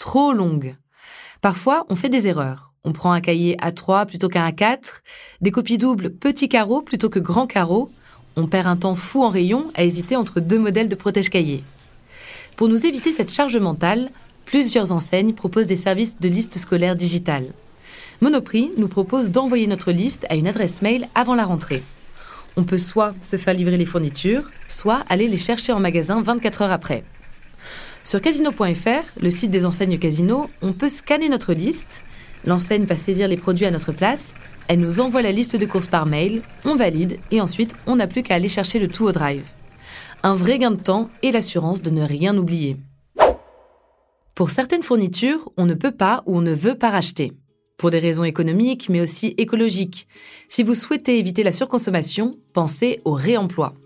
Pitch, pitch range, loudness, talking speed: 195 Hz, 175-240 Hz, -20 LUFS, 185 wpm